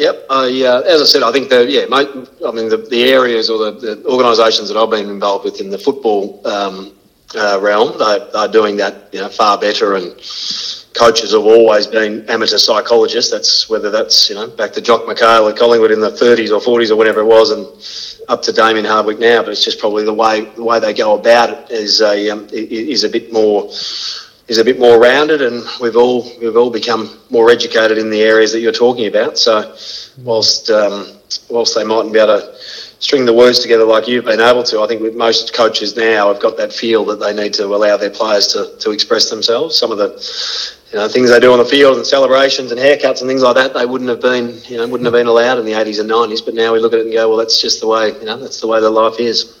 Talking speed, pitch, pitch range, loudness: 250 wpm, 115 Hz, 110-130 Hz, -12 LUFS